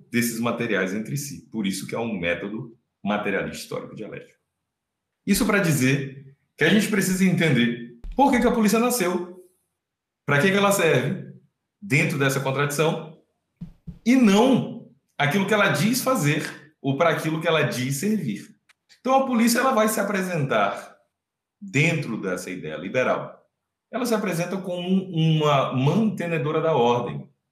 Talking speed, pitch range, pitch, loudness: 150 wpm, 135-200 Hz, 160 Hz, -22 LUFS